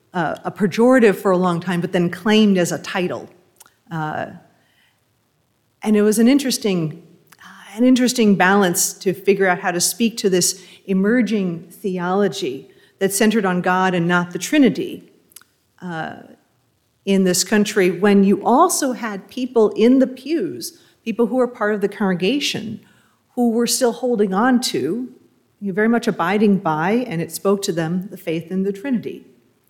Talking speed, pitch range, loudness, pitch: 165 wpm, 180-230 Hz, -18 LUFS, 200 Hz